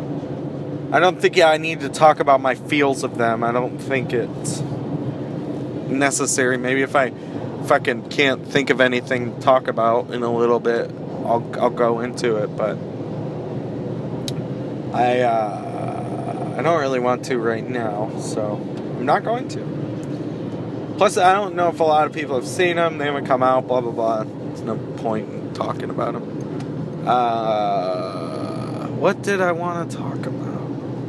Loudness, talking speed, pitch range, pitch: -21 LUFS, 170 wpm, 125-155 Hz, 140 Hz